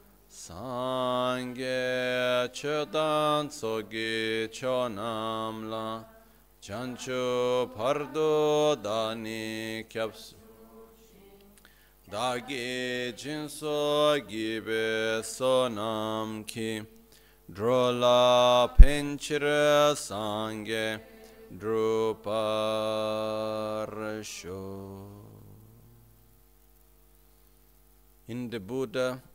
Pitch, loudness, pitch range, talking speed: 115 Hz, -29 LUFS, 110-130 Hz, 45 wpm